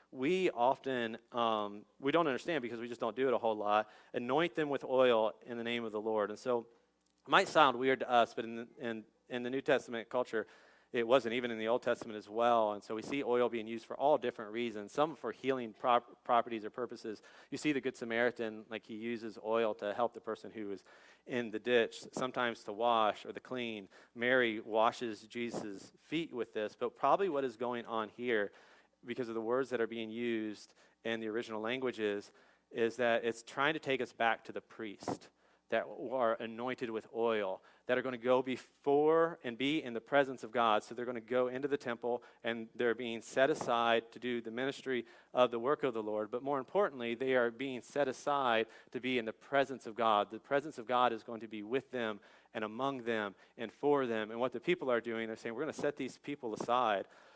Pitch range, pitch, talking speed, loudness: 115-130 Hz, 120 Hz, 225 wpm, -35 LUFS